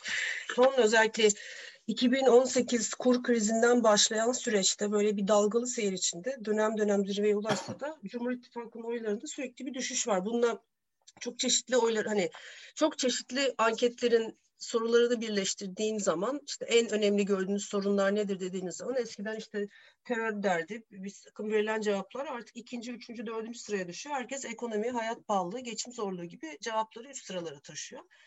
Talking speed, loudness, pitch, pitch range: 145 wpm, -30 LUFS, 225 Hz, 210-245 Hz